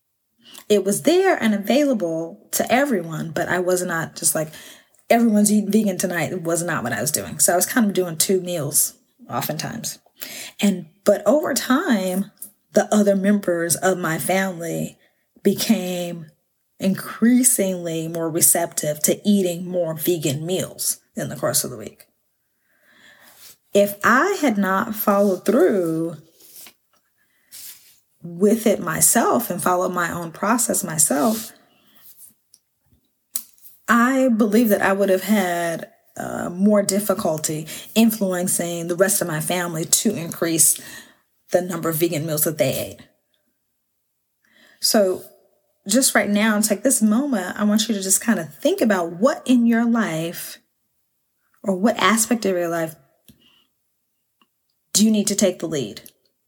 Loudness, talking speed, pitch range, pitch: -20 LUFS, 140 wpm, 175-215 Hz, 195 Hz